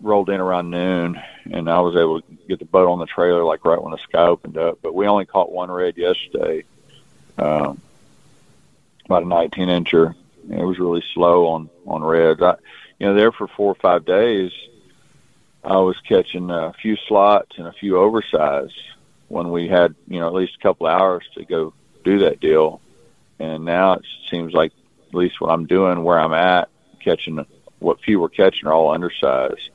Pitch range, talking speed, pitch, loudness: 85-95 Hz, 195 wpm, 90 Hz, -18 LUFS